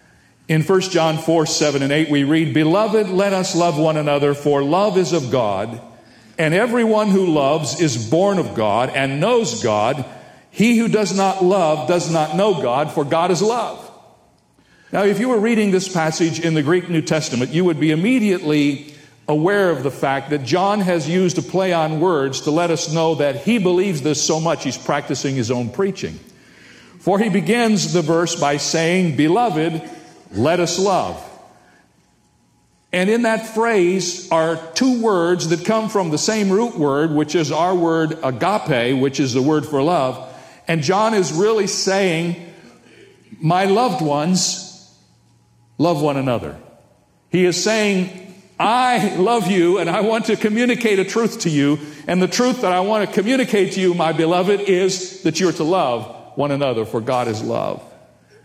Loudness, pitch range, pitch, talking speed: -18 LUFS, 150-195 Hz, 170 Hz, 175 wpm